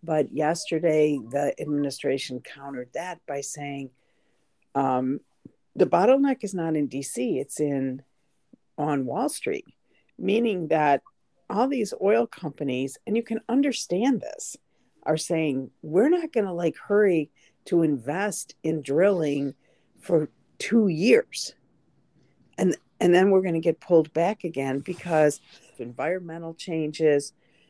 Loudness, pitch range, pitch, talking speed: -25 LUFS, 140-195 Hz, 160 Hz, 125 wpm